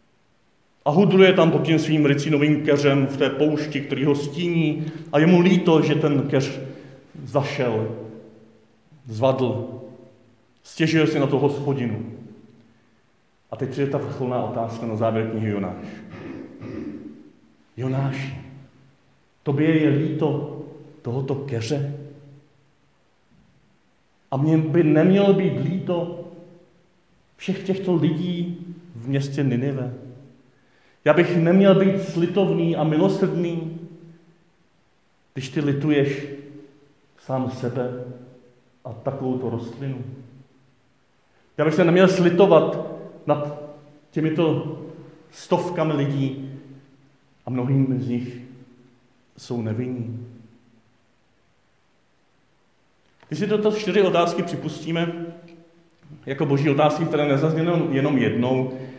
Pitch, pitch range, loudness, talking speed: 145 Hz, 130-160 Hz, -21 LUFS, 100 wpm